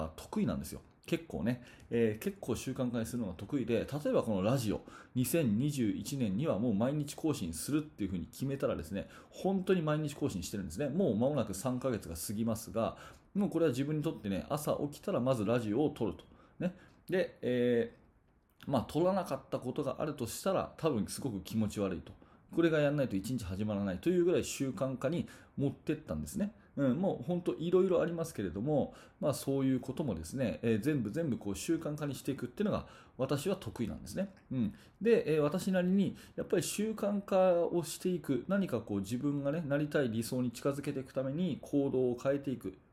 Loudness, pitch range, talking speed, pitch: -35 LUFS, 115-165 Hz, 405 characters per minute, 135 Hz